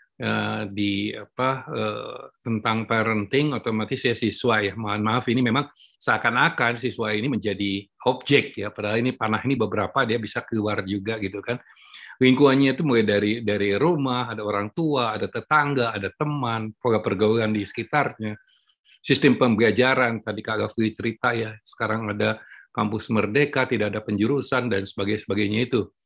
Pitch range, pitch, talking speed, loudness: 105-125 Hz, 110 Hz, 145 wpm, -23 LUFS